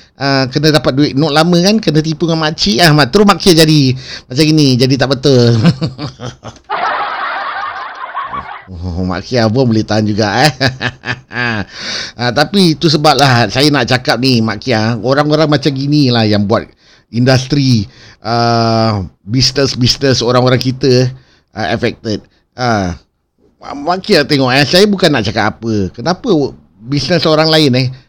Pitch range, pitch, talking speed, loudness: 115-150 Hz, 130 Hz, 150 wpm, -11 LUFS